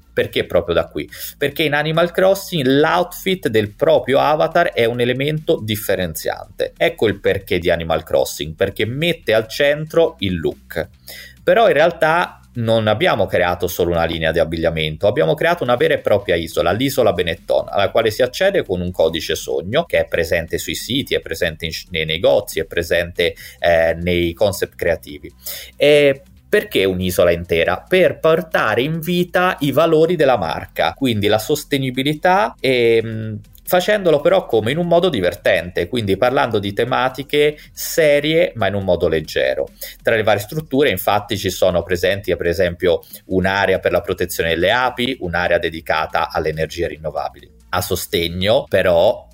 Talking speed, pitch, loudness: 155 wpm, 130 Hz, -17 LUFS